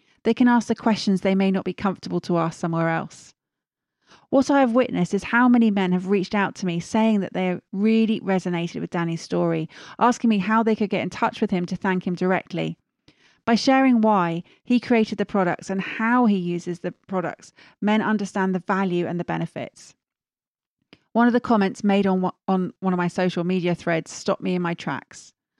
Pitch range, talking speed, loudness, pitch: 175-220 Hz, 200 wpm, -22 LUFS, 190 Hz